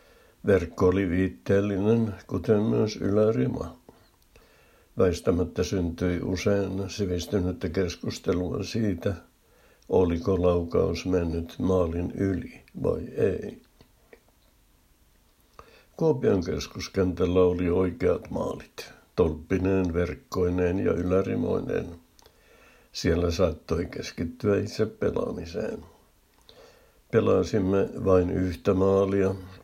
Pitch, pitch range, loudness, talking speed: 95 Hz, 90-100 Hz, -26 LUFS, 75 wpm